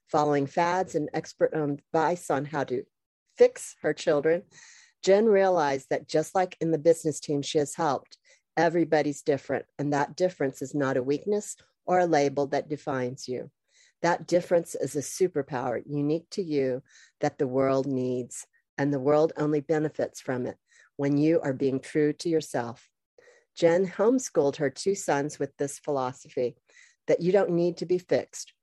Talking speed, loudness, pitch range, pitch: 165 wpm, -27 LUFS, 140-180 Hz, 155 Hz